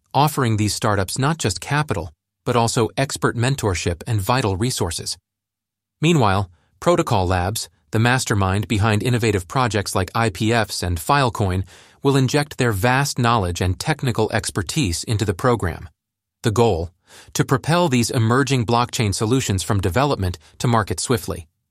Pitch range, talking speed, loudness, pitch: 100-125 Hz, 135 wpm, -20 LUFS, 110 Hz